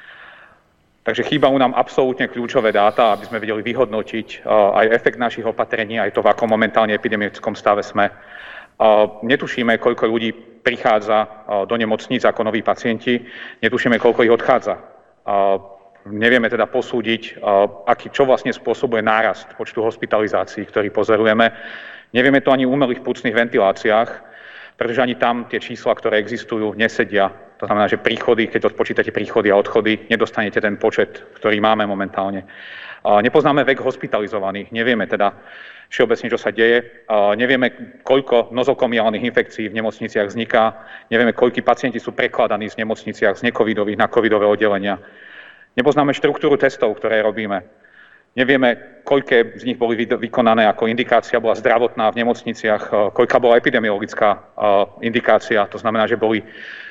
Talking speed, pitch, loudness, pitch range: 135 wpm, 115 Hz, -17 LUFS, 105-120 Hz